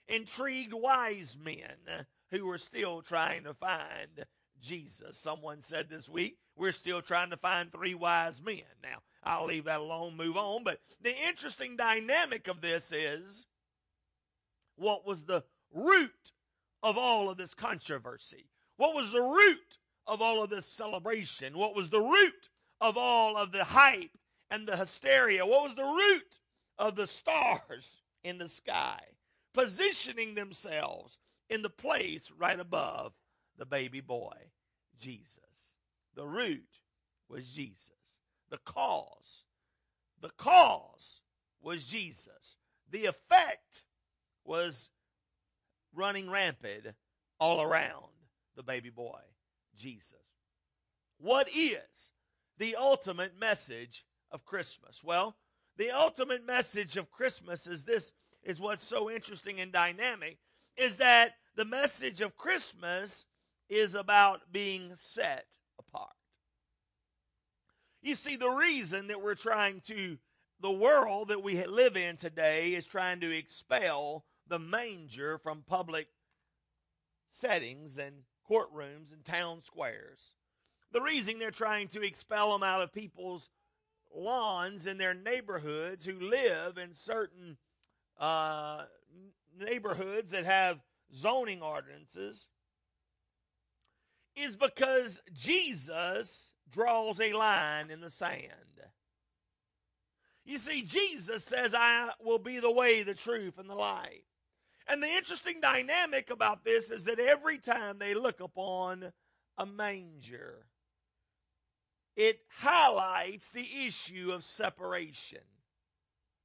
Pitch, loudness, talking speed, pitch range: 195 Hz, -32 LUFS, 120 wpm, 160-235 Hz